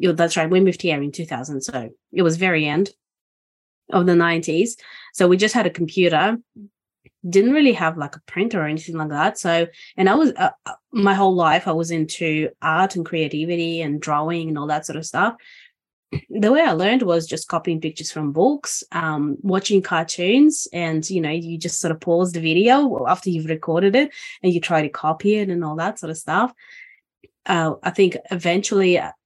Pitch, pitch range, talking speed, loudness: 170 Hz, 160-195 Hz, 195 wpm, -20 LUFS